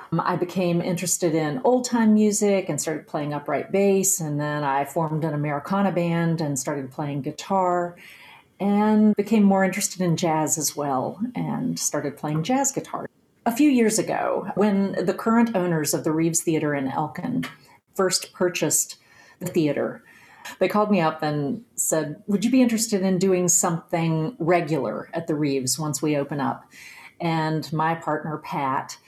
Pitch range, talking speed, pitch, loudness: 155-195 Hz, 165 wpm, 170 Hz, -23 LUFS